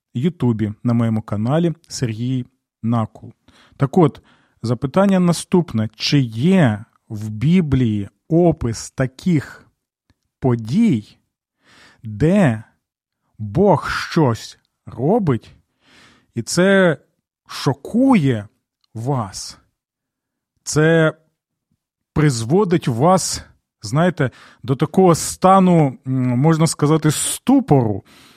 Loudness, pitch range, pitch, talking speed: -18 LUFS, 115-165 Hz, 130 Hz, 75 wpm